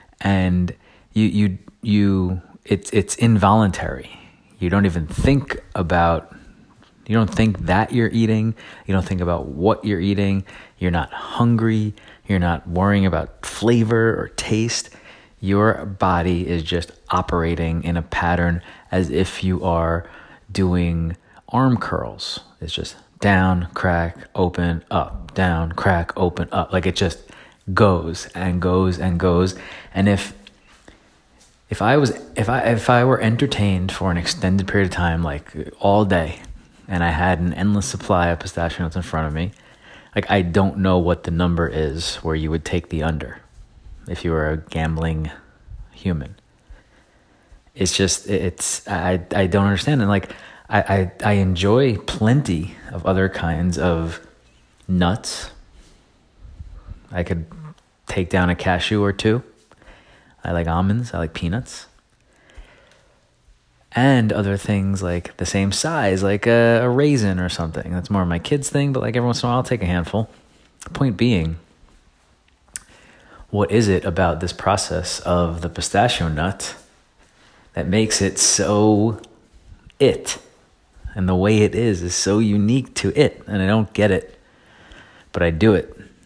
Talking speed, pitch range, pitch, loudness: 155 wpm, 85-105 Hz, 95 Hz, -20 LUFS